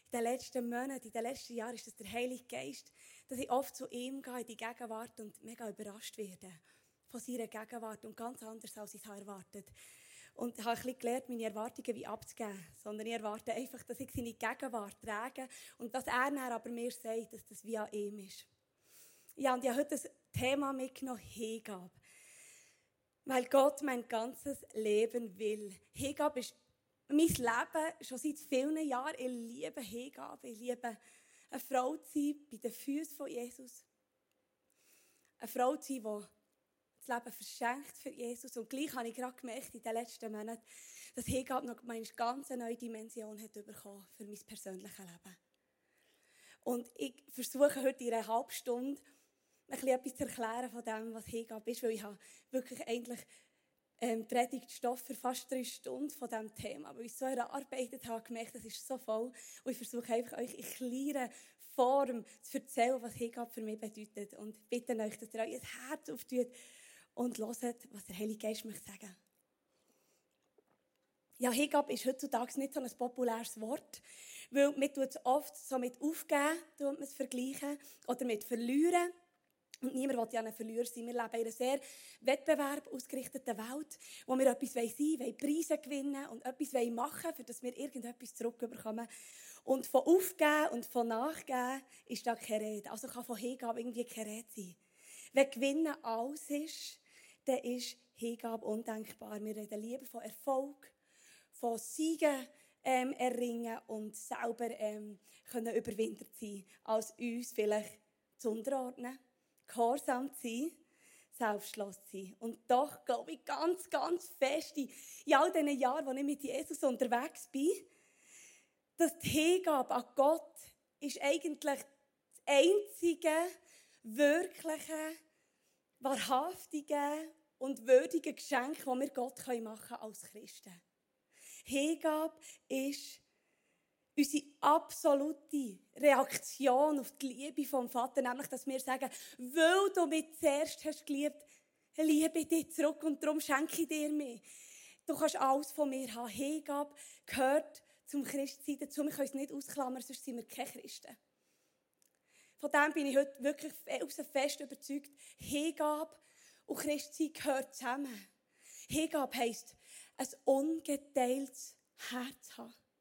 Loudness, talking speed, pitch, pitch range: -38 LUFS, 155 wpm, 255 Hz, 230-285 Hz